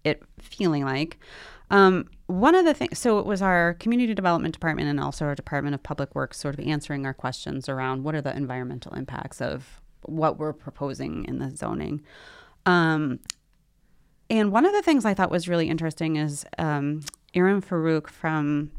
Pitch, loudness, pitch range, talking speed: 160 Hz, -25 LUFS, 145-185 Hz, 180 wpm